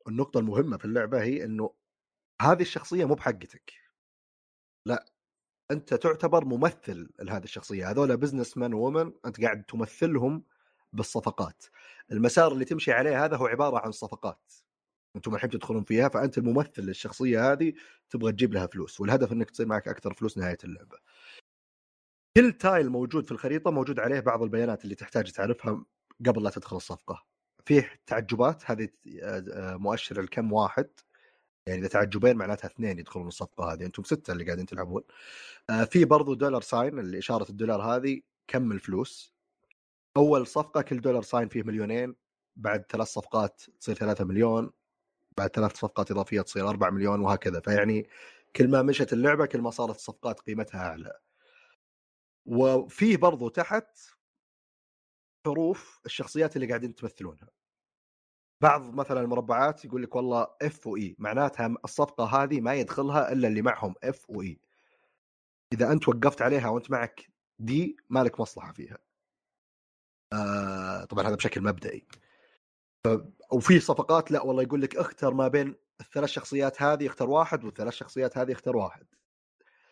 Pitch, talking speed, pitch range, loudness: 120 Hz, 145 wpm, 105-140 Hz, -28 LUFS